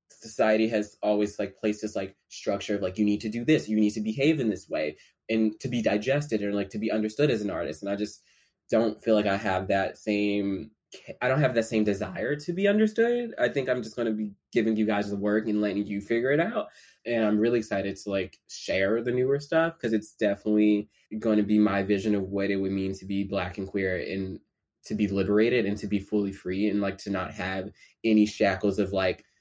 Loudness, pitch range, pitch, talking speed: -27 LUFS, 100-110 Hz, 105 Hz, 240 wpm